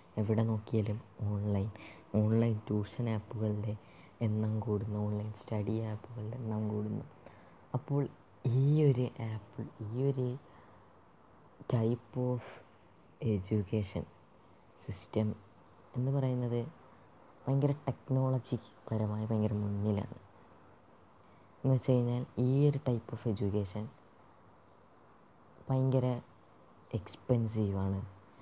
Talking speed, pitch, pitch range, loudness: 85 wpm, 110 Hz, 105-125 Hz, -35 LUFS